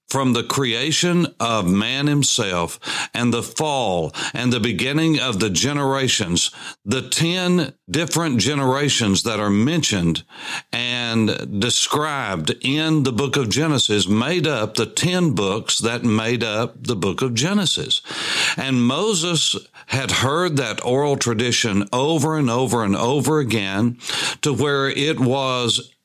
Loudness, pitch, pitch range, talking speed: -19 LUFS, 125 Hz, 115-145 Hz, 135 wpm